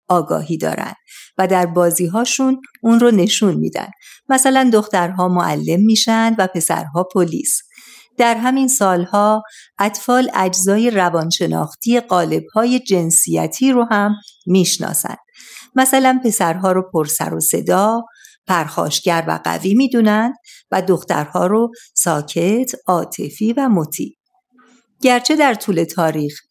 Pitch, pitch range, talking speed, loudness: 210 Hz, 175-245 Hz, 110 wpm, -16 LUFS